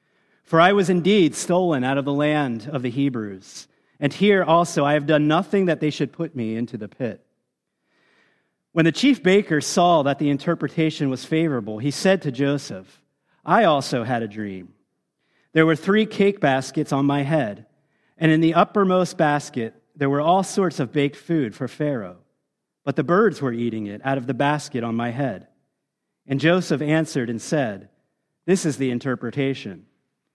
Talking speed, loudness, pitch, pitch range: 180 wpm, -21 LUFS, 150 Hz, 130-170 Hz